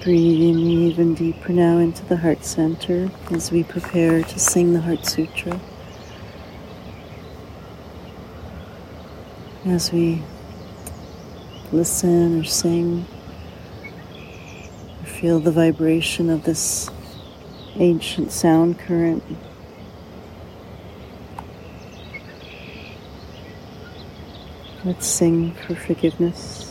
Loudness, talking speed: -19 LUFS, 75 wpm